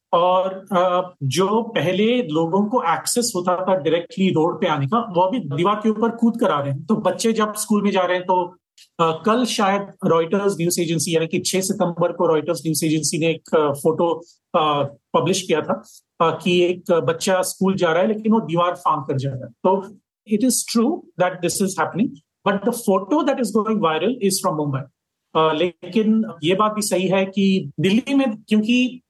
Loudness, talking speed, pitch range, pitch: -20 LUFS, 195 wpm, 170-215 Hz, 185 Hz